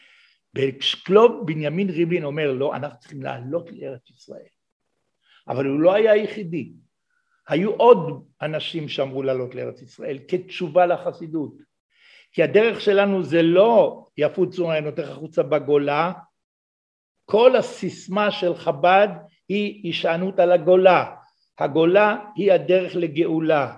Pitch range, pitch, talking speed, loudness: 155-195 Hz, 175 Hz, 120 wpm, -20 LUFS